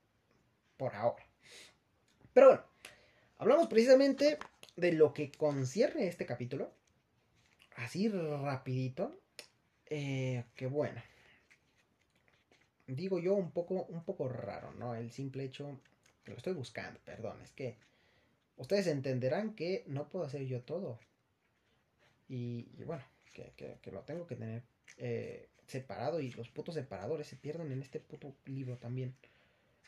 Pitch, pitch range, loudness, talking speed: 135 Hz, 120-155 Hz, -35 LUFS, 135 wpm